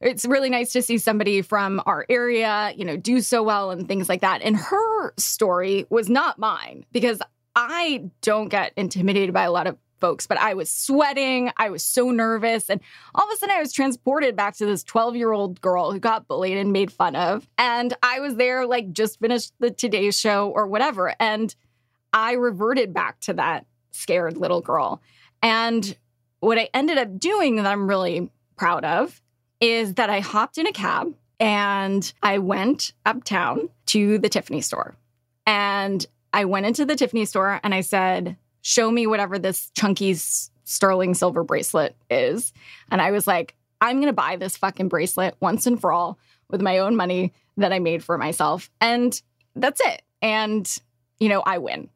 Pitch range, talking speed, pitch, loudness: 190-240 Hz, 185 wpm, 210 Hz, -22 LUFS